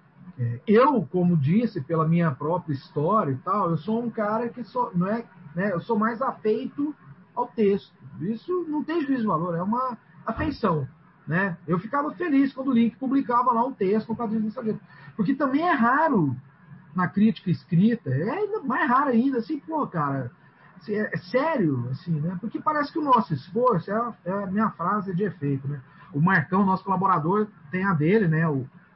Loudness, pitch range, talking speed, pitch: -25 LUFS, 165-240 Hz, 180 wpm, 200 Hz